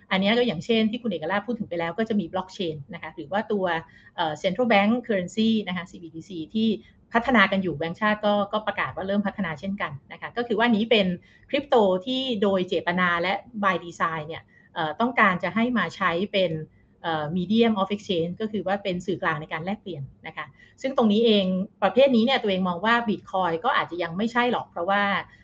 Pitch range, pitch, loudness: 170-220 Hz, 195 Hz, -24 LUFS